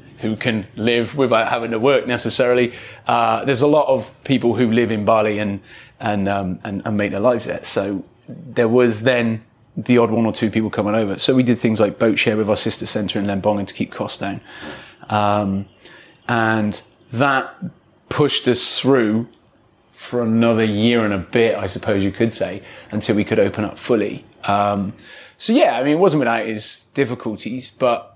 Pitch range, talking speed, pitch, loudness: 105-120 Hz, 190 wpm, 110 Hz, -18 LUFS